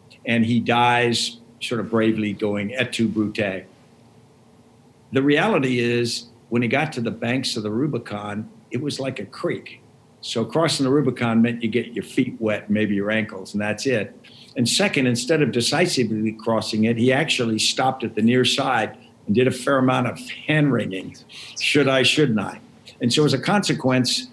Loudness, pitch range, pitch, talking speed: -21 LUFS, 110-130 Hz, 120 Hz, 185 wpm